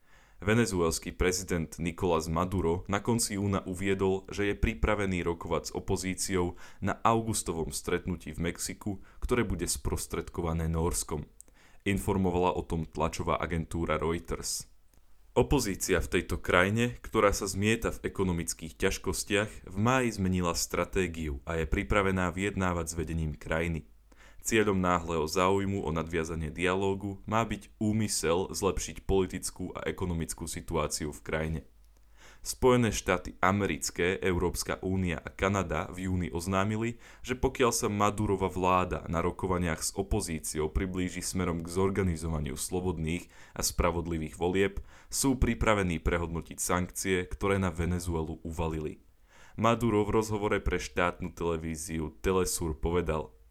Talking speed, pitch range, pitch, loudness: 120 wpm, 80-100 Hz, 90 Hz, -31 LUFS